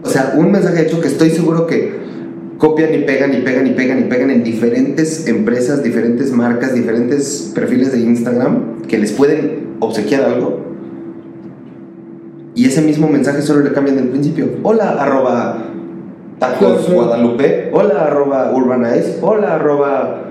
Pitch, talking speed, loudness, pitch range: 135 Hz, 150 wpm, -13 LUFS, 120-155 Hz